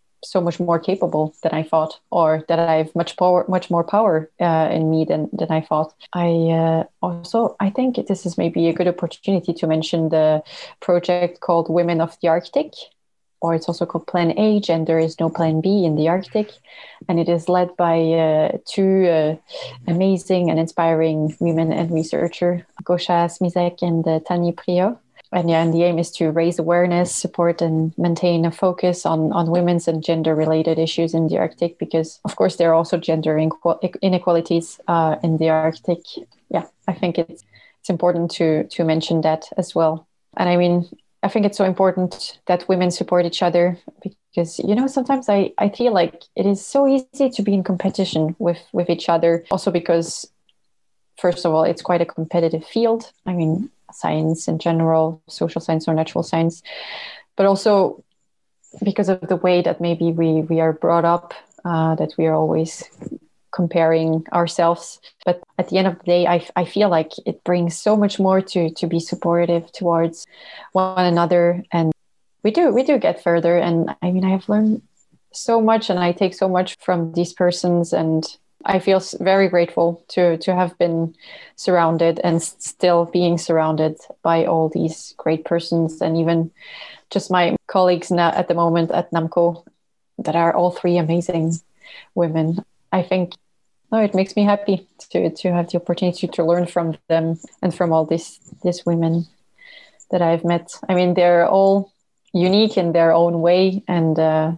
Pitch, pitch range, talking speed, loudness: 170 Hz, 165-185 Hz, 180 wpm, -19 LUFS